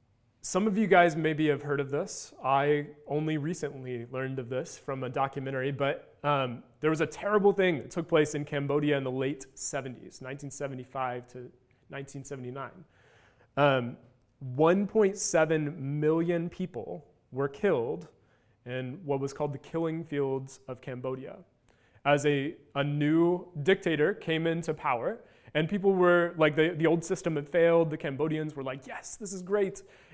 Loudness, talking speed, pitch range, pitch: -29 LUFS, 155 wpm, 130-165 Hz, 145 Hz